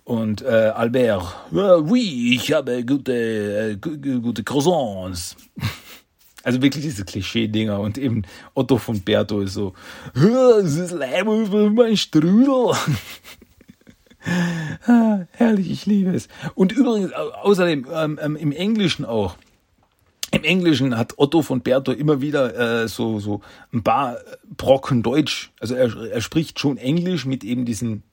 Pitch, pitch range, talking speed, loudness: 140 Hz, 115-180 Hz, 140 wpm, -20 LUFS